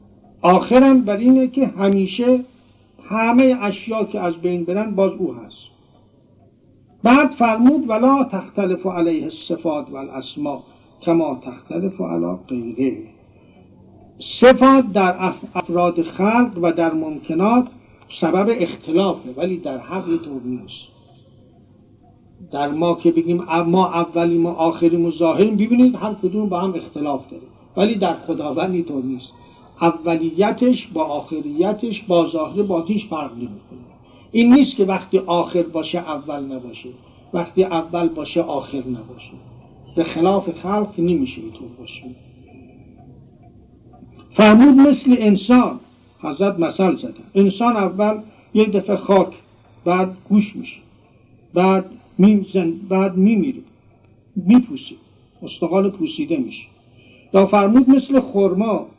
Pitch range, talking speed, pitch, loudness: 145-210 Hz, 115 wpm, 175 Hz, -17 LUFS